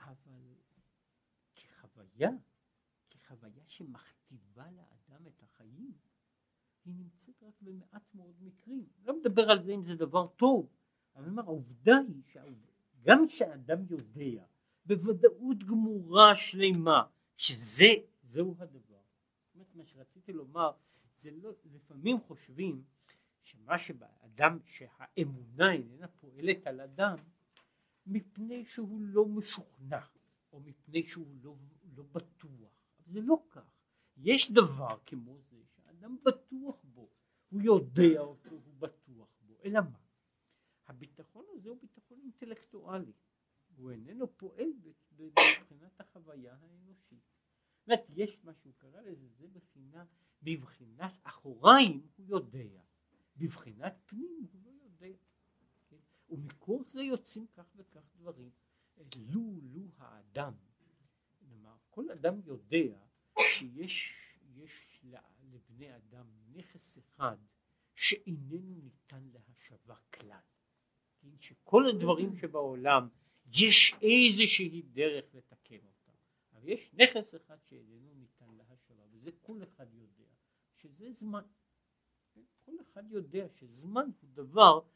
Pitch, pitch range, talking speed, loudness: 165 Hz, 135-205 Hz, 110 wpm, -28 LUFS